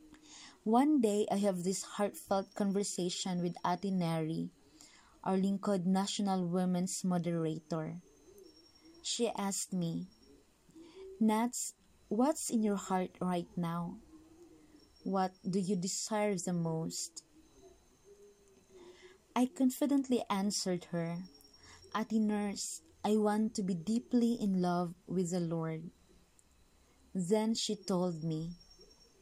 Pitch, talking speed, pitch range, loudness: 200 Hz, 105 wpm, 180-235 Hz, -35 LUFS